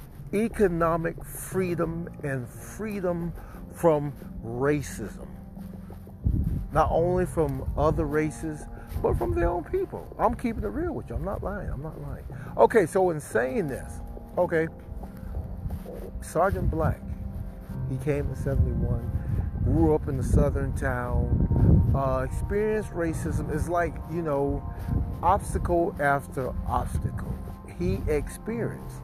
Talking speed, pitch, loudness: 115 wpm, 140 Hz, -27 LUFS